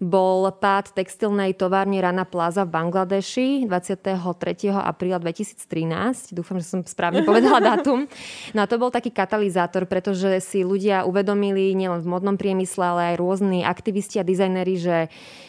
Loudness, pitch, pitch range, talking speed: -22 LUFS, 190 Hz, 180-200 Hz, 145 wpm